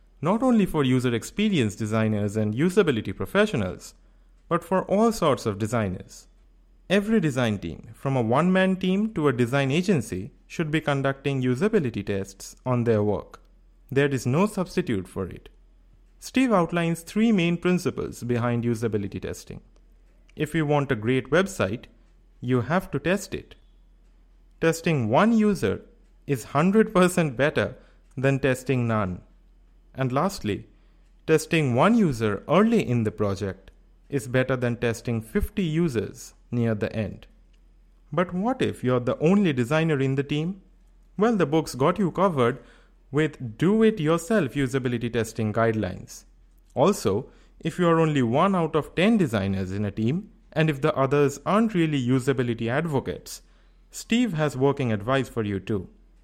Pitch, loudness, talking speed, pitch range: 140 Hz, -24 LUFS, 145 wpm, 115-175 Hz